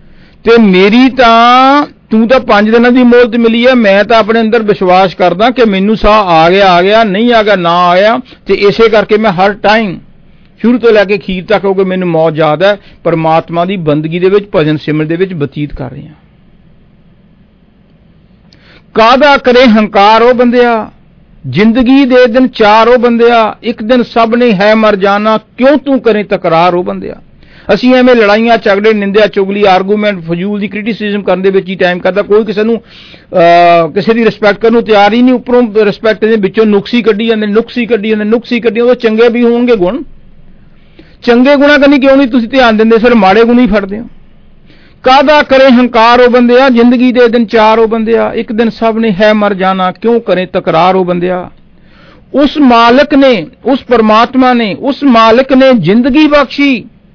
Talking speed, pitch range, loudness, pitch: 190 wpm, 190-240 Hz, -7 LUFS, 220 Hz